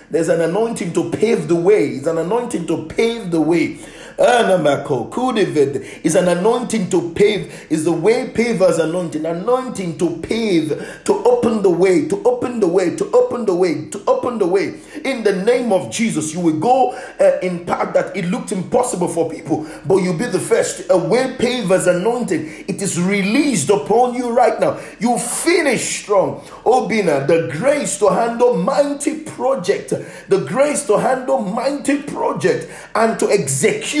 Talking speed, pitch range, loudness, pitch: 170 wpm, 180-270 Hz, -17 LUFS, 225 Hz